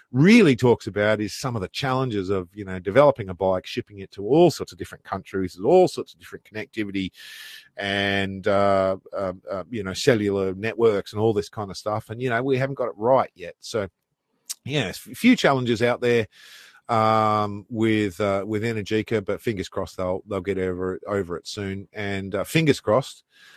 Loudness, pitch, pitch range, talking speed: -23 LUFS, 105 Hz, 100-120 Hz, 195 wpm